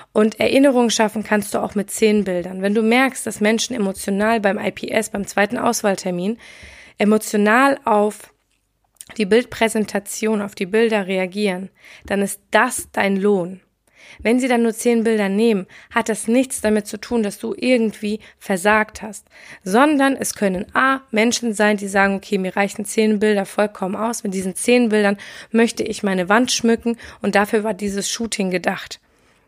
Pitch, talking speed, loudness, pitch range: 215 Hz, 165 wpm, -19 LUFS, 200-230 Hz